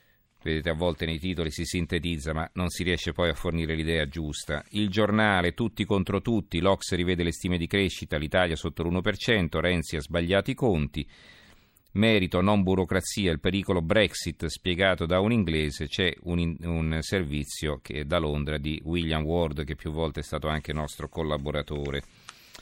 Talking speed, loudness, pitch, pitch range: 170 wpm, -27 LUFS, 85 Hz, 80-95 Hz